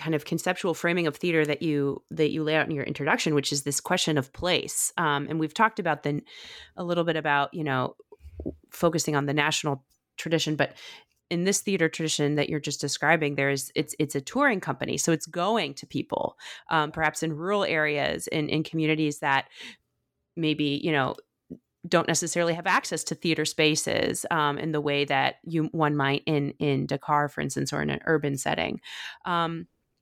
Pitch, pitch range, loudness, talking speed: 155 Hz, 145-170 Hz, -26 LUFS, 195 wpm